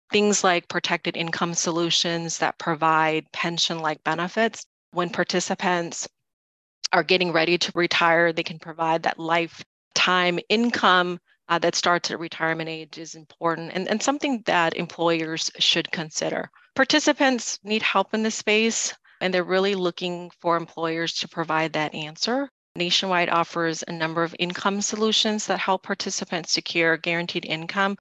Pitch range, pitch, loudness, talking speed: 165-195 Hz, 175 Hz, -23 LUFS, 145 wpm